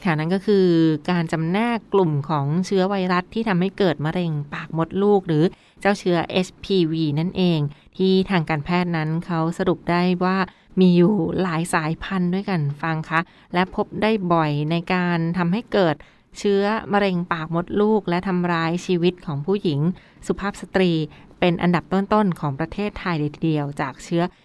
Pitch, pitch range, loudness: 175 Hz, 165-190 Hz, -21 LUFS